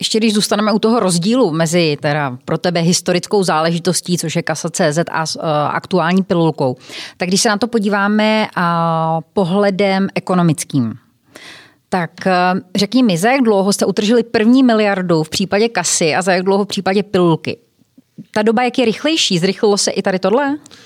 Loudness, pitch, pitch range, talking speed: -15 LUFS, 190 Hz, 165-210 Hz, 165 wpm